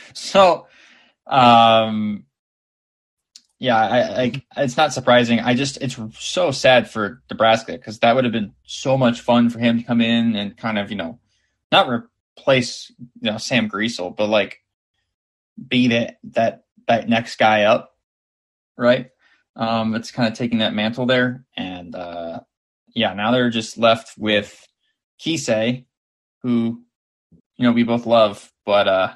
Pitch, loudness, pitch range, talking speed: 115 Hz, -18 LUFS, 110-125 Hz, 150 wpm